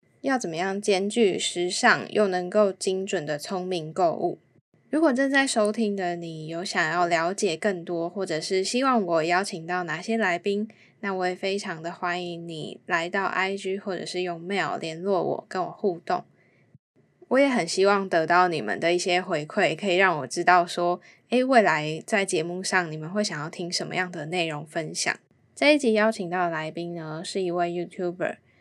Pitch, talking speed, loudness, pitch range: 180 Hz, 285 characters per minute, -25 LUFS, 170-200 Hz